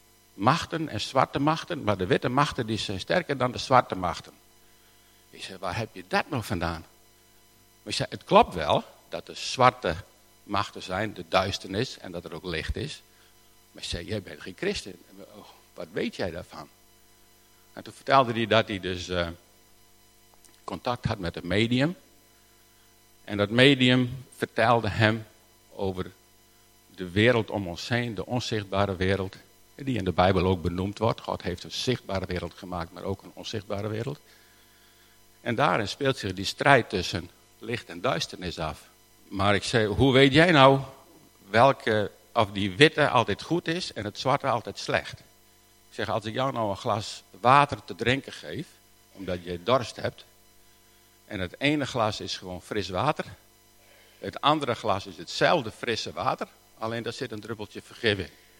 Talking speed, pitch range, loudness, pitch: 170 wpm, 90-120 Hz, -26 LUFS, 100 Hz